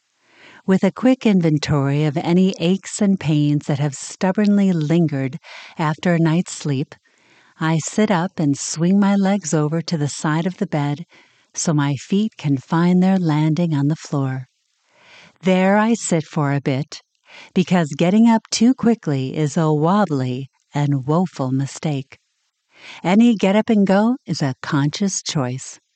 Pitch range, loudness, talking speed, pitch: 145-195 Hz, -19 LUFS, 155 wpm, 165 Hz